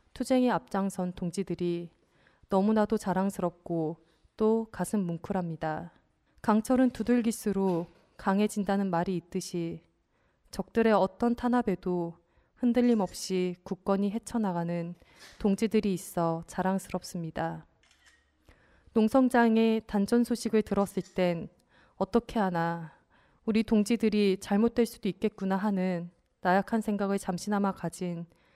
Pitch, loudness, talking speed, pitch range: 195 Hz, -29 LUFS, 265 characters per minute, 175-220 Hz